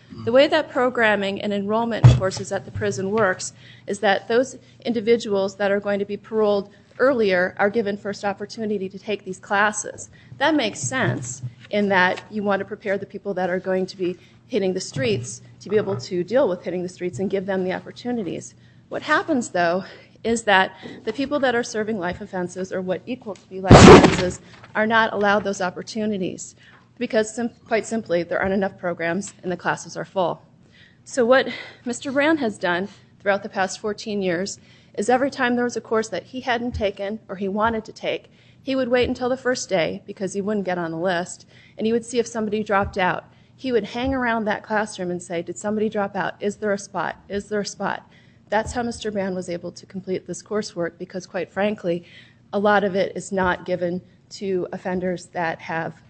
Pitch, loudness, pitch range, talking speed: 200 Hz, -22 LUFS, 185-225 Hz, 205 wpm